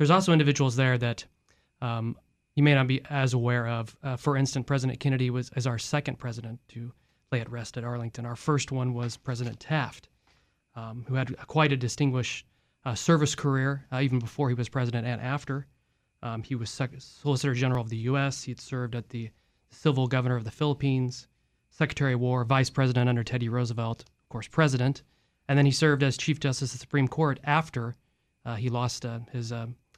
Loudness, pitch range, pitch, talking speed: -28 LUFS, 120-140 Hz, 125 Hz, 200 wpm